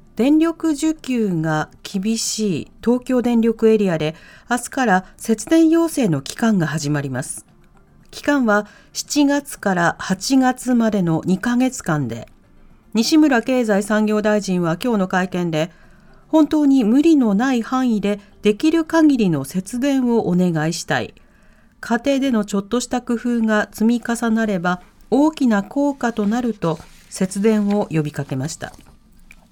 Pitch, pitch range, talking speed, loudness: 220 Hz, 185-255 Hz, 265 characters per minute, -19 LUFS